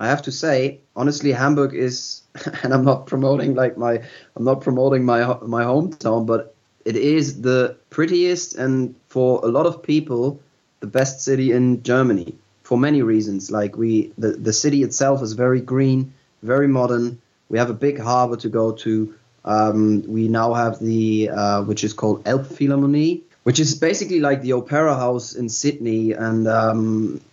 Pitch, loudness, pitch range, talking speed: 125 Hz, -19 LUFS, 115-140 Hz, 170 wpm